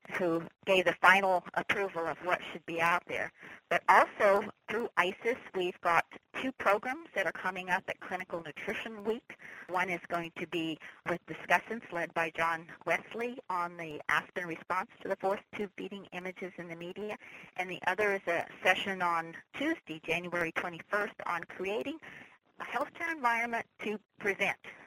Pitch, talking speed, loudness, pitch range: 185 Hz, 165 wpm, -33 LUFS, 170-205 Hz